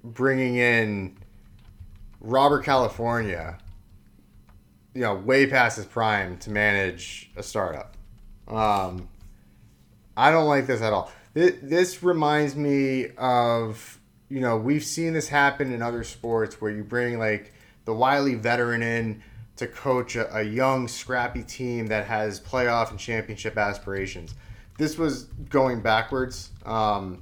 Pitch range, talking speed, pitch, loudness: 105-130 Hz, 135 wpm, 115 Hz, -24 LUFS